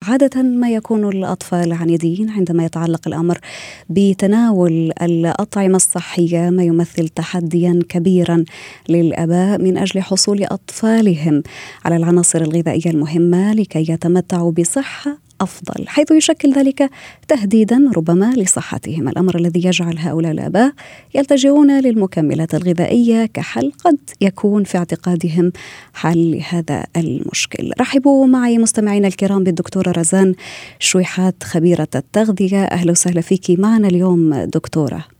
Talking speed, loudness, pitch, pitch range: 110 wpm, -15 LUFS, 180 Hz, 170-215 Hz